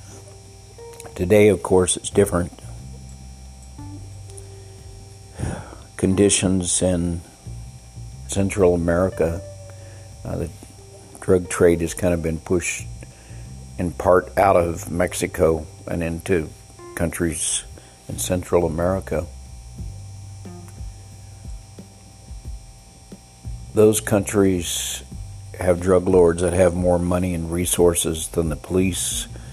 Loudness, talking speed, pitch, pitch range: -20 LUFS, 85 wpm, 90 Hz, 85-100 Hz